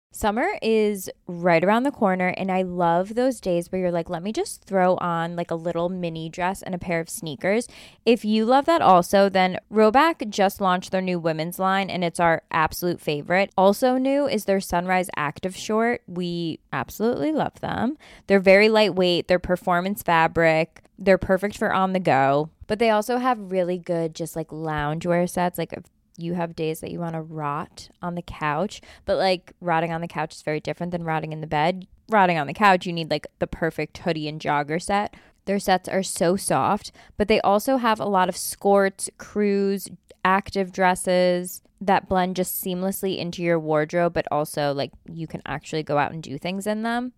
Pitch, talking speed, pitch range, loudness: 180 Hz, 195 wpm, 165-195 Hz, -23 LUFS